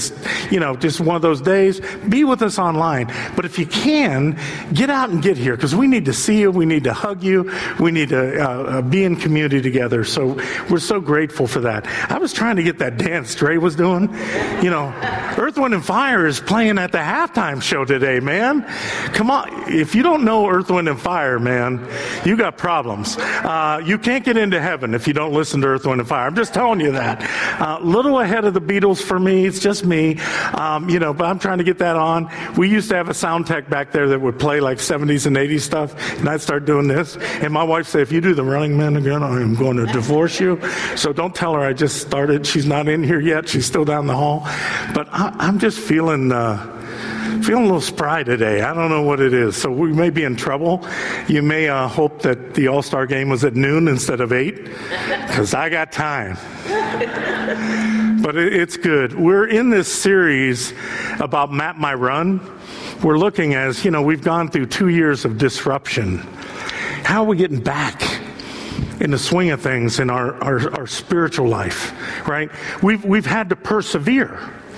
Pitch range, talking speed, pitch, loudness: 135-190 Hz, 220 wpm, 160 Hz, -18 LUFS